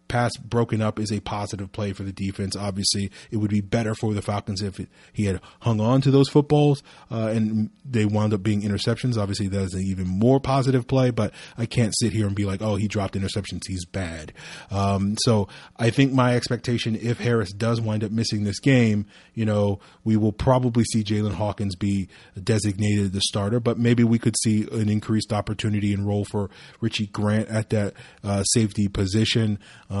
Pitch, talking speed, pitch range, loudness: 110 Hz, 200 wpm, 100-115 Hz, -23 LUFS